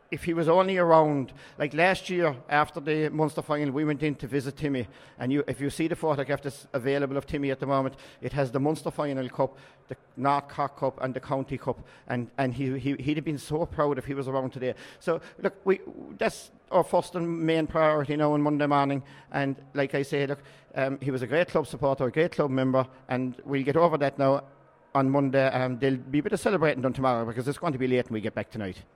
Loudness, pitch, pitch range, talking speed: -27 LUFS, 140 Hz, 135-155 Hz, 245 wpm